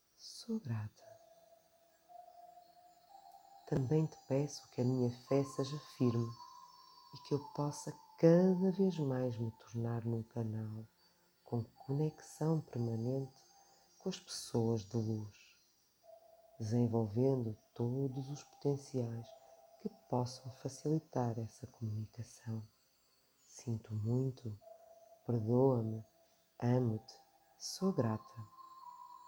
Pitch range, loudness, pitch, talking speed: 115-190 Hz, -38 LUFS, 130 Hz, 90 wpm